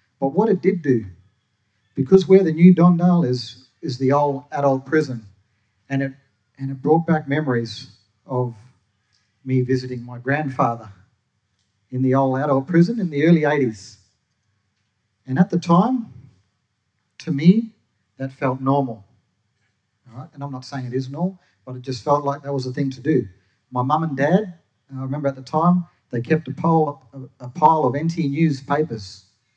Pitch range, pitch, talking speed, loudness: 110-150 Hz, 130 Hz, 175 wpm, -20 LUFS